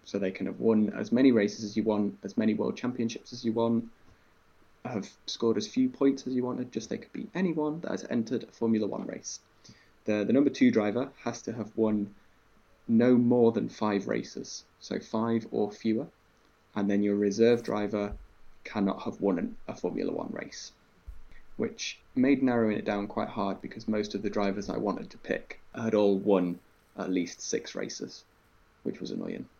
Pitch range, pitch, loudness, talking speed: 100-120 Hz, 110 Hz, -30 LUFS, 195 wpm